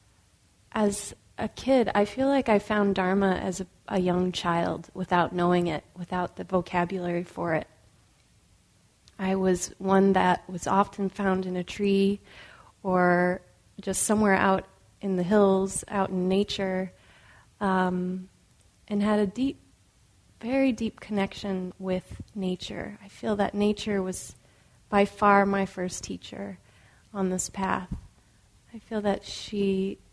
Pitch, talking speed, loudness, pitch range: 190 Hz, 135 wpm, -27 LUFS, 180-200 Hz